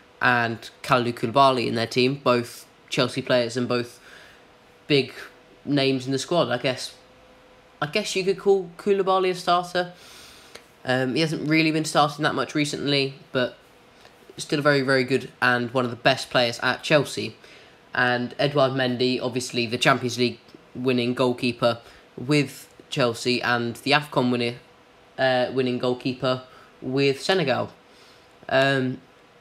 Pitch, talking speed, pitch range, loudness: 130 Hz, 145 wpm, 125-145 Hz, -23 LUFS